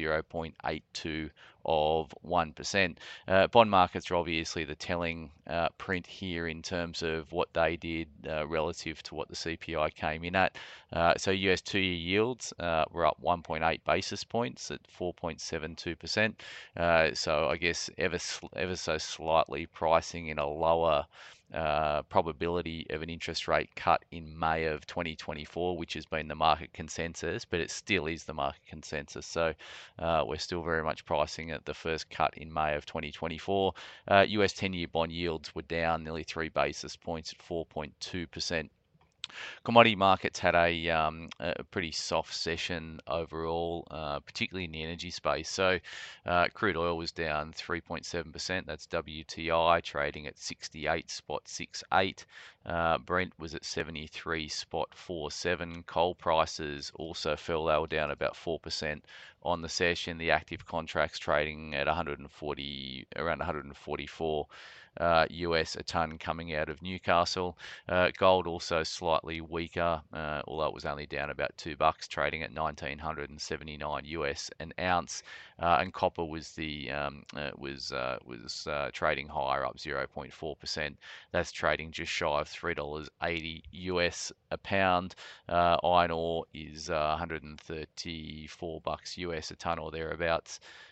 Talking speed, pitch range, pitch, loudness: 150 wpm, 75-85 Hz, 80 Hz, -32 LUFS